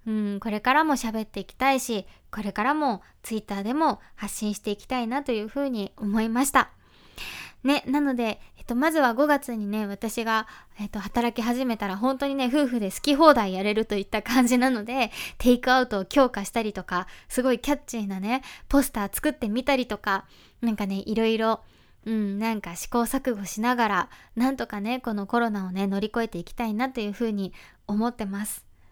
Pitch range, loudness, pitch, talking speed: 210-255 Hz, -26 LUFS, 225 Hz, 380 characters per minute